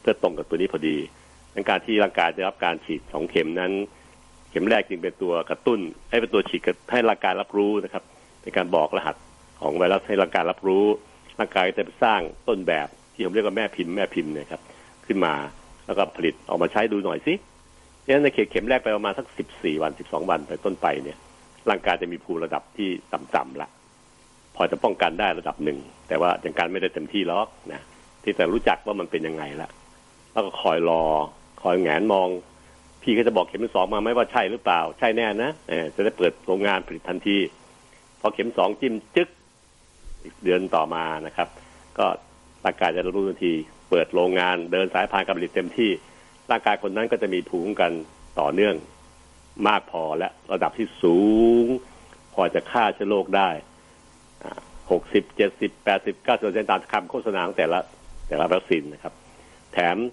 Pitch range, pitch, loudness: 80-95 Hz, 85 Hz, -24 LUFS